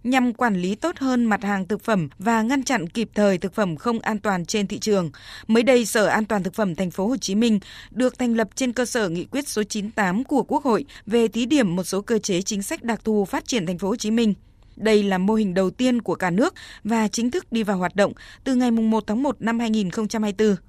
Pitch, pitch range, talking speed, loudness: 220 Hz, 200-245 Hz, 255 wpm, -22 LUFS